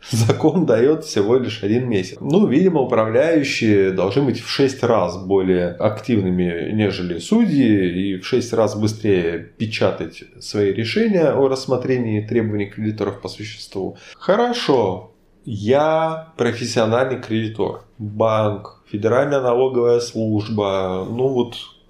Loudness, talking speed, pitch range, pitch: -19 LUFS, 115 wpm, 105-125 Hz, 110 Hz